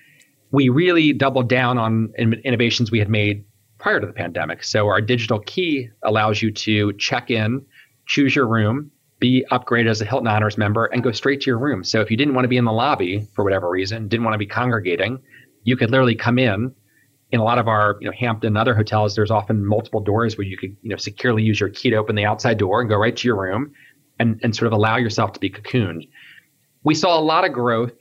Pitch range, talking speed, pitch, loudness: 105-130 Hz, 240 wpm, 115 Hz, -19 LUFS